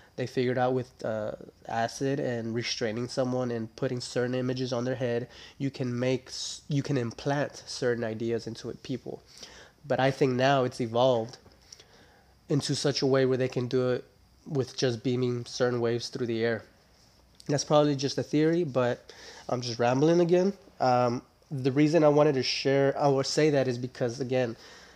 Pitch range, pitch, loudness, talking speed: 120-140 Hz, 130 Hz, -28 LUFS, 175 wpm